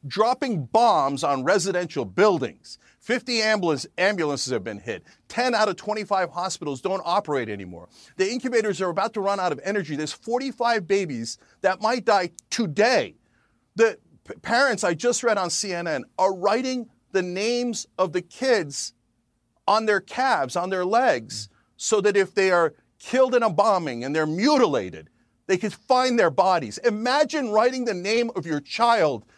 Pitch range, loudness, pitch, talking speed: 160-230 Hz, -23 LUFS, 195 Hz, 160 wpm